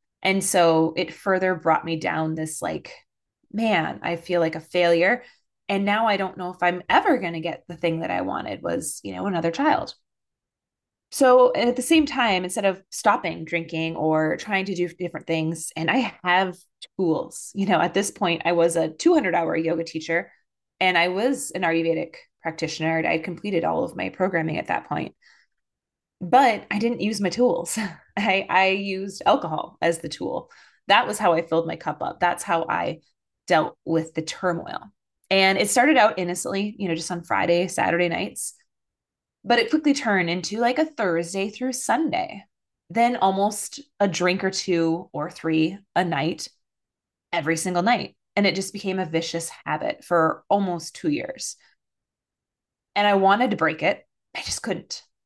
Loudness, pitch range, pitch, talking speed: -23 LUFS, 165-210 Hz, 185 Hz, 180 wpm